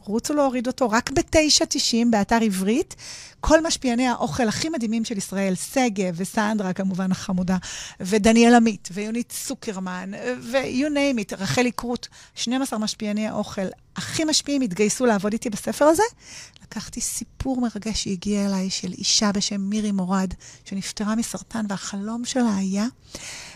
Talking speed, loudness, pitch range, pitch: 135 wpm, -23 LUFS, 200-245 Hz, 220 Hz